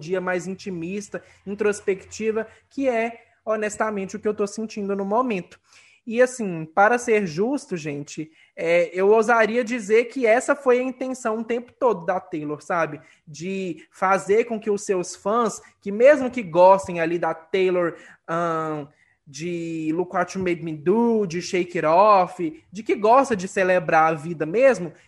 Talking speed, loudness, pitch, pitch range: 165 wpm, -22 LUFS, 195 Hz, 170-225 Hz